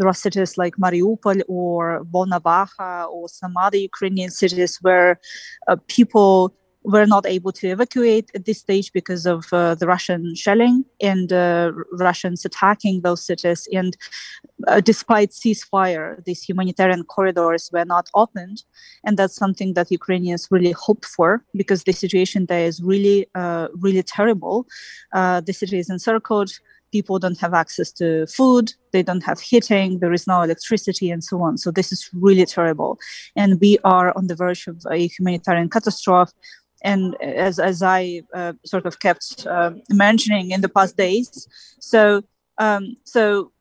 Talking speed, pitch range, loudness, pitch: 160 wpm, 175-205 Hz, -19 LUFS, 185 Hz